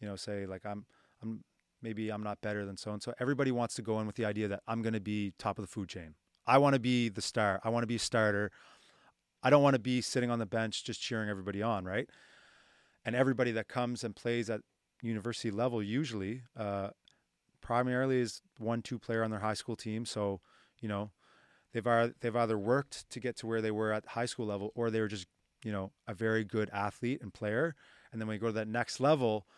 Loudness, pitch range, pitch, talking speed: -34 LUFS, 105-120 Hz, 110 Hz, 240 wpm